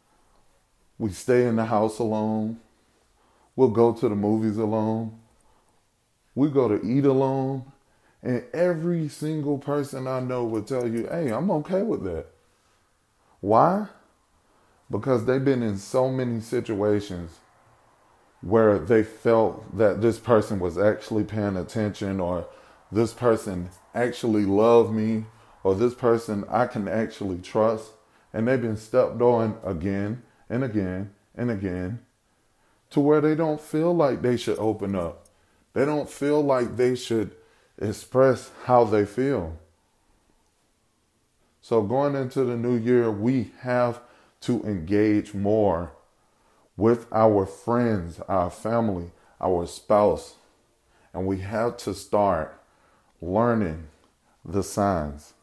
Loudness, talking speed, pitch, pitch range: -24 LUFS, 130 wpm, 110 Hz, 105-125 Hz